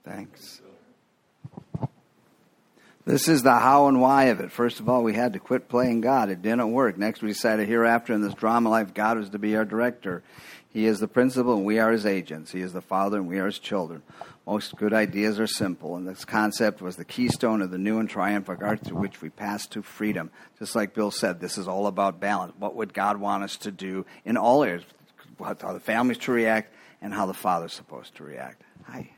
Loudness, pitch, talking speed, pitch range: -25 LUFS, 105 Hz, 225 wpm, 100-115 Hz